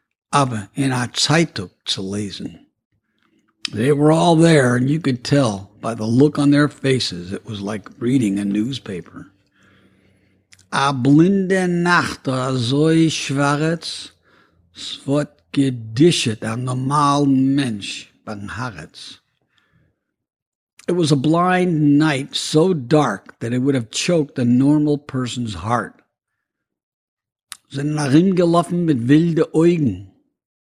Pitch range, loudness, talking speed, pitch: 115-155 Hz, -18 LUFS, 110 wpm, 140 Hz